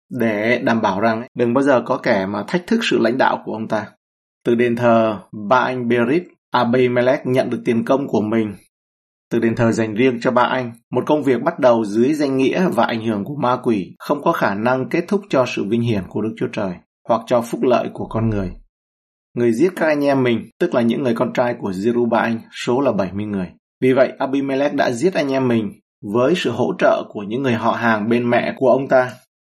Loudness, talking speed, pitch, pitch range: -18 LUFS, 235 wpm, 120 Hz, 110-130 Hz